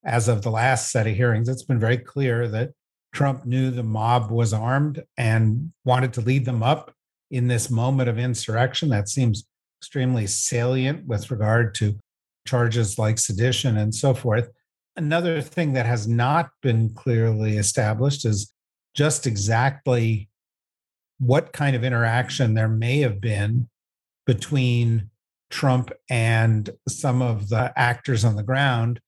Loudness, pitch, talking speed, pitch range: -22 LUFS, 120 Hz, 145 wpm, 110-130 Hz